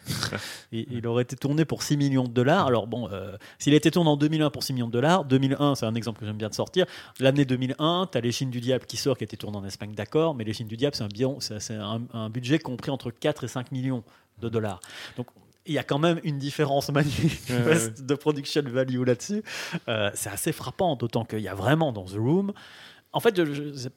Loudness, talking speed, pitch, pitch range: -26 LUFS, 240 wpm, 130 Hz, 115-145 Hz